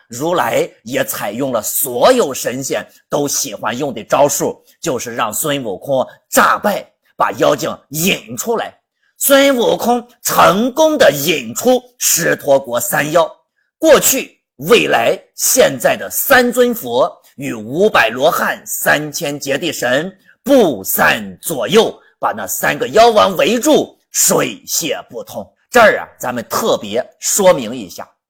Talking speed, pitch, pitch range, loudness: 195 characters per minute, 245 Hz, 185-275 Hz, -14 LUFS